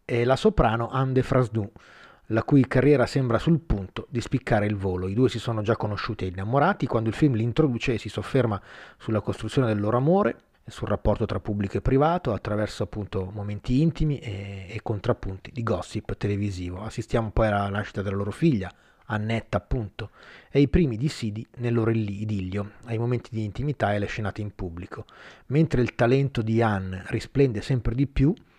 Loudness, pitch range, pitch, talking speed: -26 LUFS, 105-130 Hz, 115 Hz, 185 wpm